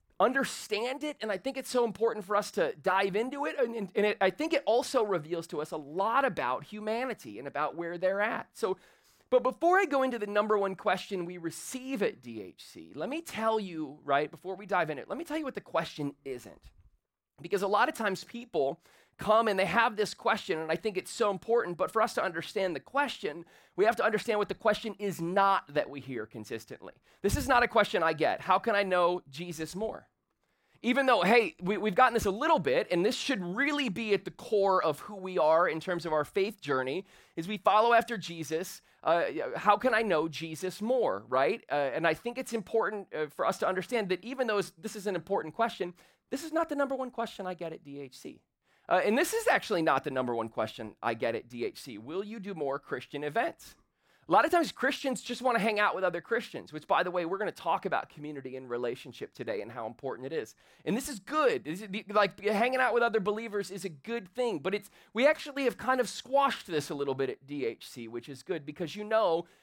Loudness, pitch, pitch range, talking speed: -31 LUFS, 205 Hz, 165-235 Hz, 240 wpm